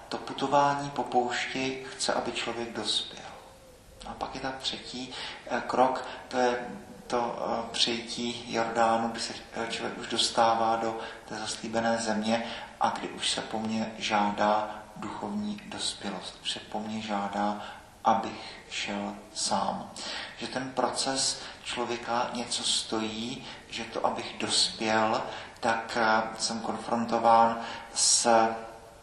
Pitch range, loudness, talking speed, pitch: 110-120 Hz, -29 LUFS, 120 wpm, 115 Hz